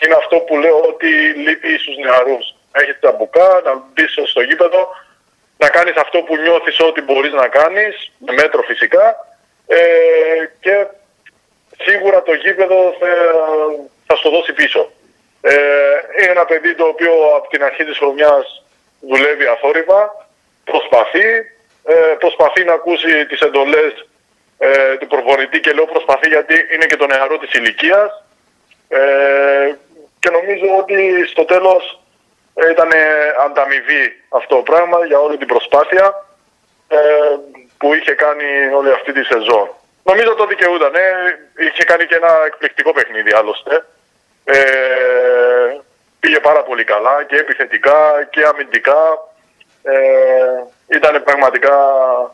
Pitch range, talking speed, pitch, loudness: 145-220 Hz, 135 wpm, 170 Hz, -12 LUFS